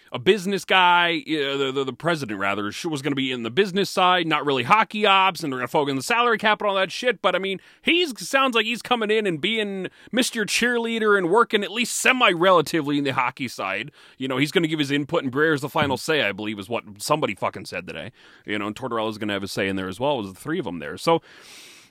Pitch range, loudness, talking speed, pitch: 135-205 Hz, -22 LUFS, 270 wpm, 165 Hz